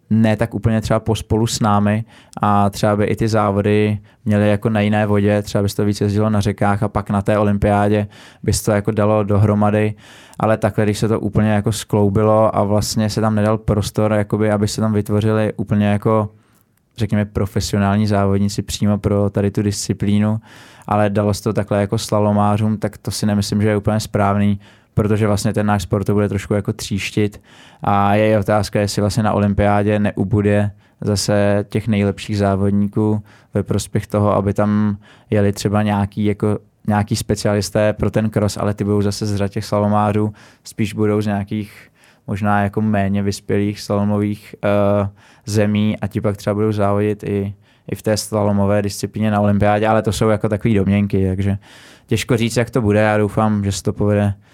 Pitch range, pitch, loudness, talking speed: 100-110 Hz, 105 Hz, -18 LUFS, 185 wpm